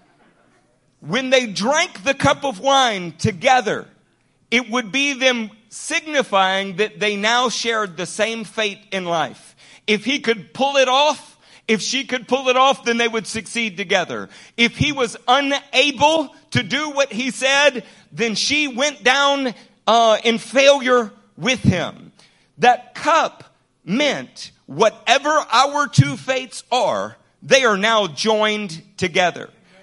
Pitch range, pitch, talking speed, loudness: 215-275 Hz, 240 Hz, 140 wpm, -18 LUFS